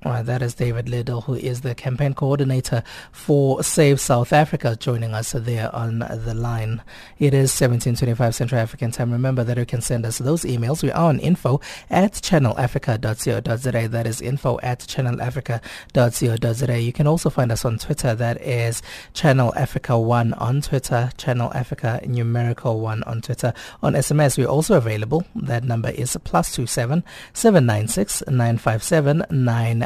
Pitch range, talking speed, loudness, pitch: 115-140 Hz, 160 wpm, -21 LUFS, 125 Hz